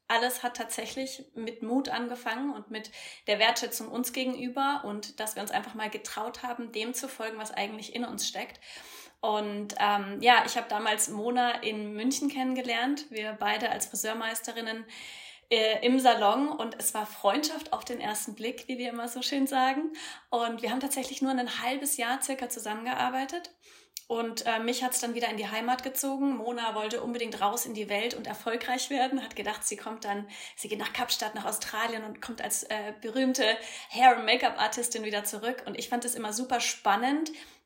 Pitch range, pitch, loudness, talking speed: 220-260 Hz, 240 Hz, -30 LUFS, 190 wpm